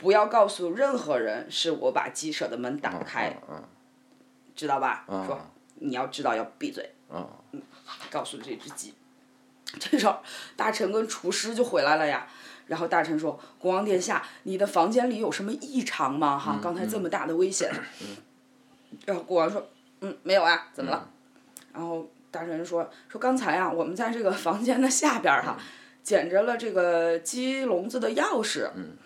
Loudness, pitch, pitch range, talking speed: -27 LUFS, 225 Hz, 175-265 Hz, 245 characters per minute